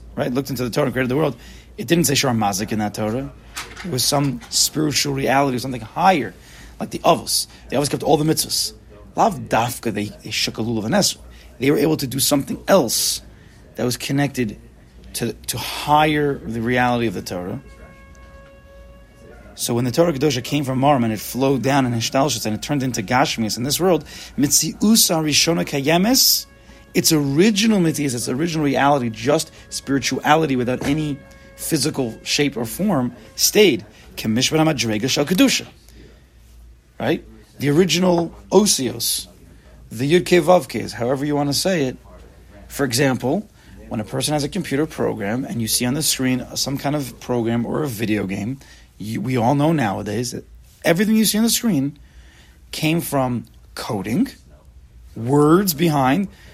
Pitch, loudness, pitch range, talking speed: 130 Hz, -19 LUFS, 110-150 Hz, 155 wpm